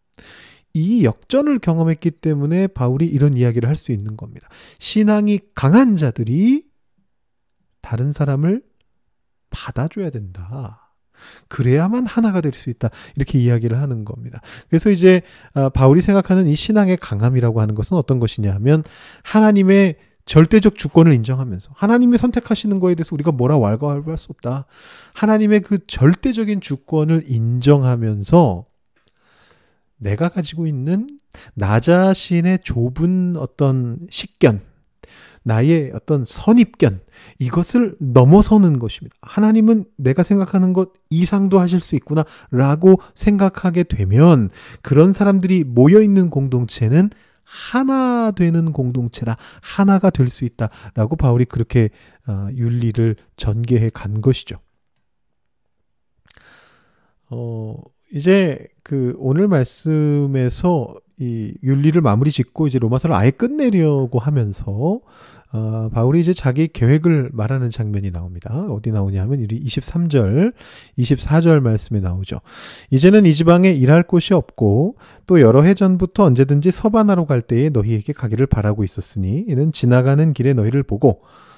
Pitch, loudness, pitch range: 145 Hz, -16 LUFS, 120-185 Hz